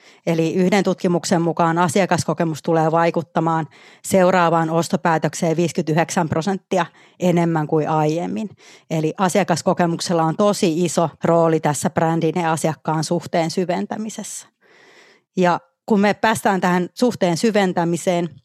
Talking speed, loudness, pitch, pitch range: 105 wpm, -19 LUFS, 170 Hz, 165-185 Hz